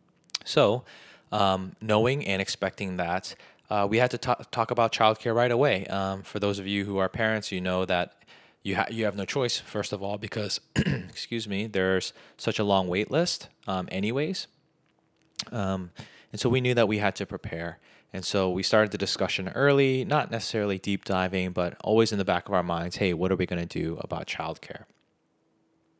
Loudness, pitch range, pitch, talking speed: -27 LUFS, 95-110 Hz, 100 Hz, 195 wpm